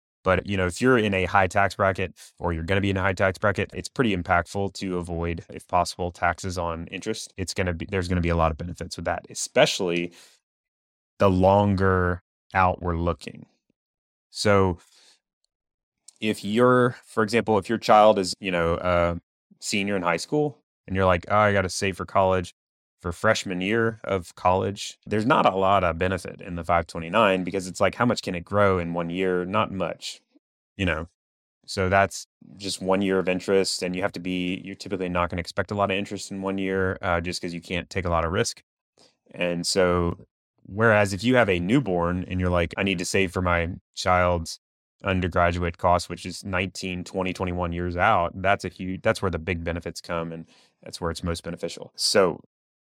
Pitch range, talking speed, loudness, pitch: 85-100 Hz, 210 wpm, -24 LUFS, 95 Hz